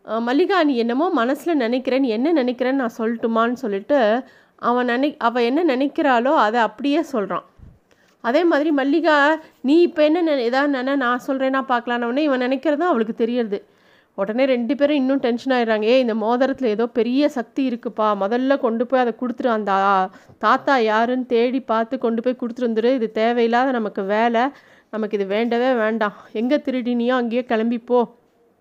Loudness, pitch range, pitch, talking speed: -20 LUFS, 230-270 Hz, 245 Hz, 150 wpm